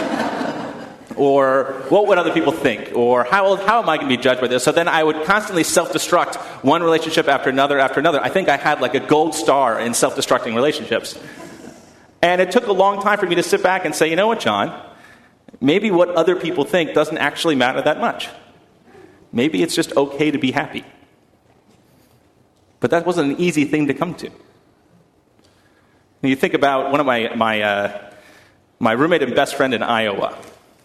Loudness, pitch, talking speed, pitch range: -17 LUFS, 155 Hz, 195 wpm, 135-180 Hz